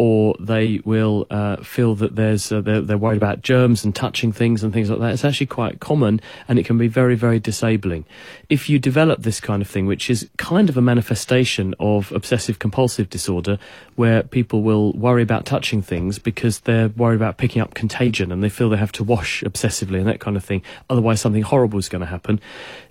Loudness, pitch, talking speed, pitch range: -19 LUFS, 110 Hz, 215 wpm, 105-120 Hz